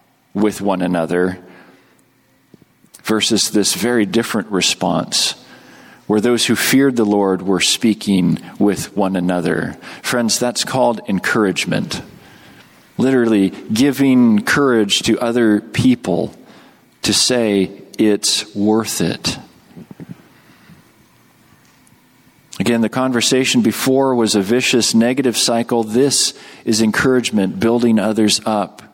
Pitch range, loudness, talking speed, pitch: 100-120 Hz, -16 LUFS, 100 wpm, 110 Hz